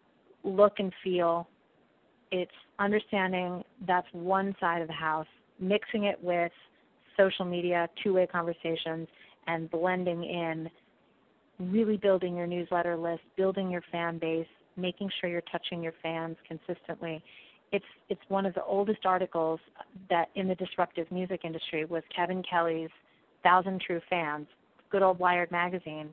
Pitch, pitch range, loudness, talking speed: 175 Hz, 170-190 Hz, -31 LUFS, 140 wpm